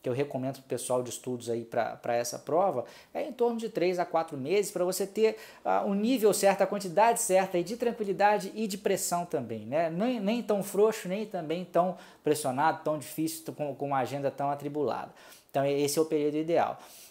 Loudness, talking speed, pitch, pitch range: -30 LUFS, 215 wpm, 175 Hz, 145-205 Hz